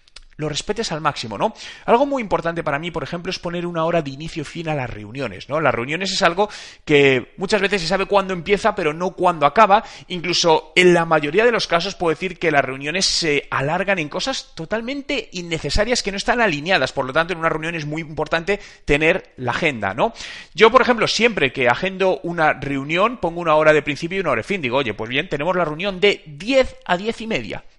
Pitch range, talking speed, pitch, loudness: 150-200 Hz, 220 wpm, 170 Hz, -19 LUFS